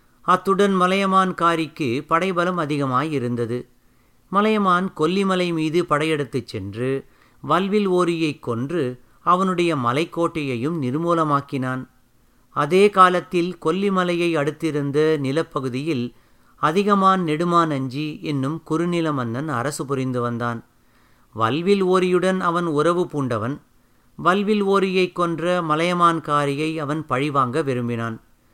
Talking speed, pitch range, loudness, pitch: 90 wpm, 130-175 Hz, -21 LUFS, 155 Hz